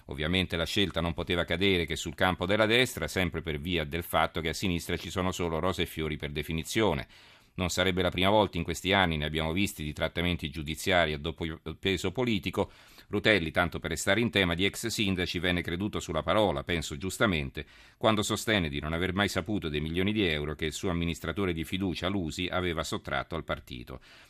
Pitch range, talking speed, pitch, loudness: 80-100 Hz, 205 wpm, 90 Hz, -29 LUFS